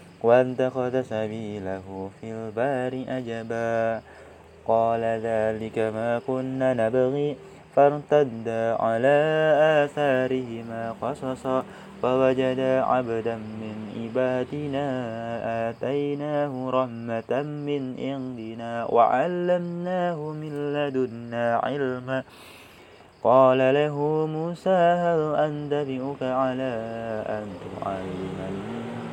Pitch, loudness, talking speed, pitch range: 130 Hz, -25 LUFS, 70 wpm, 115-145 Hz